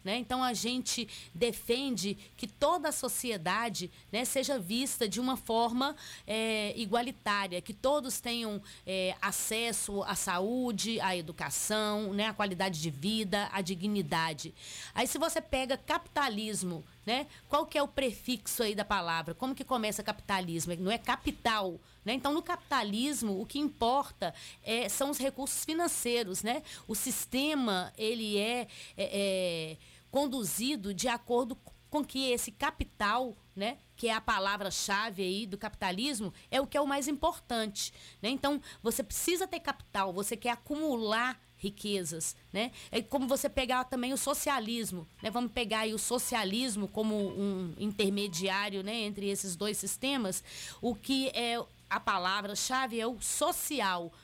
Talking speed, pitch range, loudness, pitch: 150 wpm, 200-260 Hz, -33 LUFS, 230 Hz